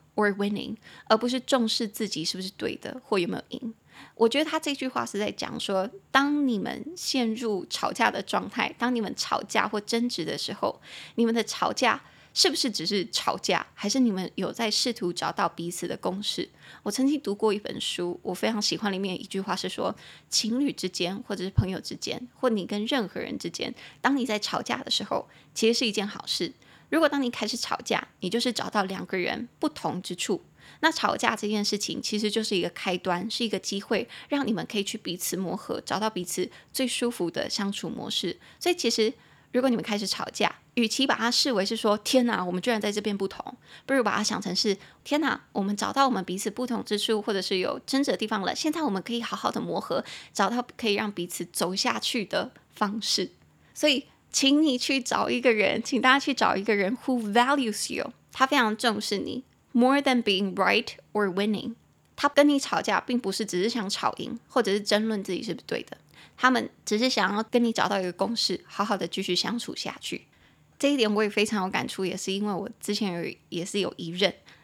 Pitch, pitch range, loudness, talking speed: 220 Hz, 195-245 Hz, -27 LUFS, 340 characters per minute